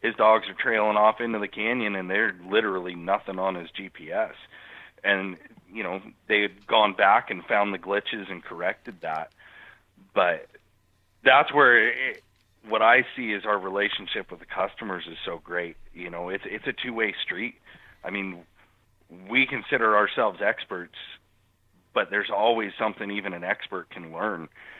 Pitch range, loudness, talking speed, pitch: 95-105 Hz, -25 LUFS, 170 wpm, 100 Hz